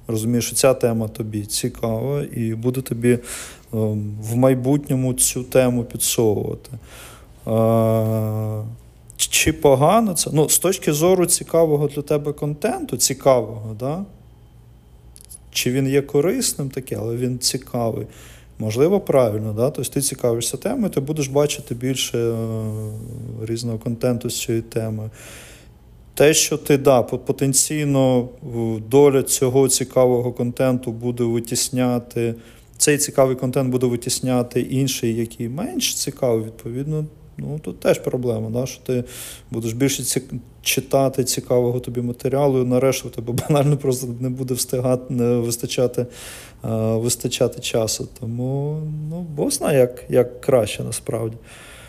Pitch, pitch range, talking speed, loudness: 125 Hz, 115-135 Hz, 125 wpm, -20 LUFS